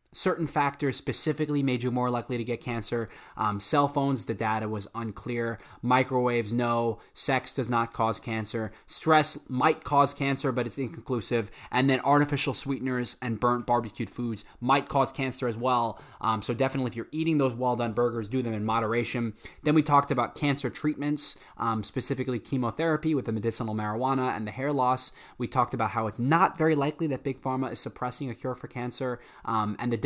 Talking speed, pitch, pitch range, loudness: 190 wpm, 125 Hz, 115-140 Hz, -28 LUFS